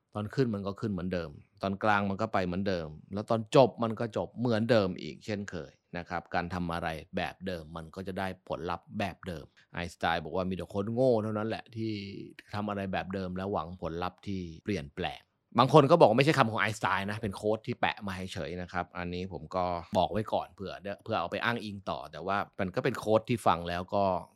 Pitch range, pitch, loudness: 90-110 Hz, 95 Hz, -31 LUFS